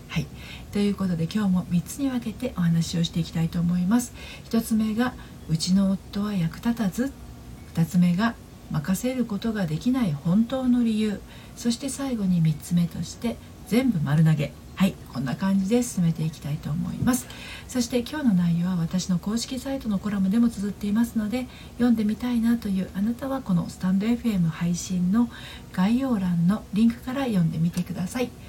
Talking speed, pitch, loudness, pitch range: 355 characters per minute, 200 Hz, -25 LUFS, 175-235 Hz